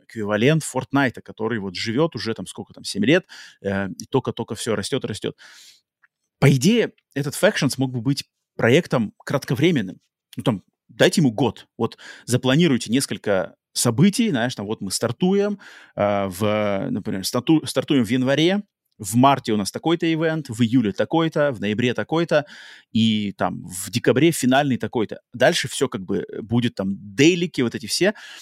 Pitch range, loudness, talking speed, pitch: 110-150 Hz, -21 LUFS, 160 wpm, 125 Hz